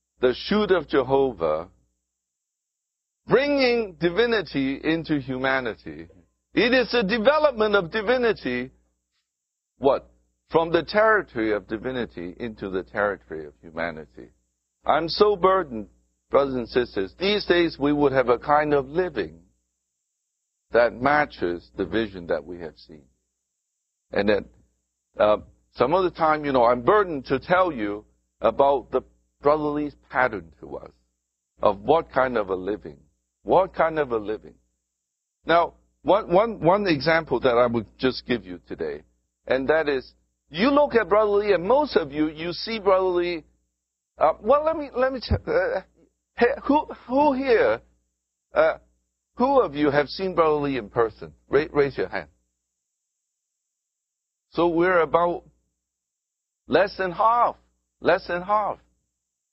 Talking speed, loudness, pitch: 140 wpm, -23 LUFS, 130 Hz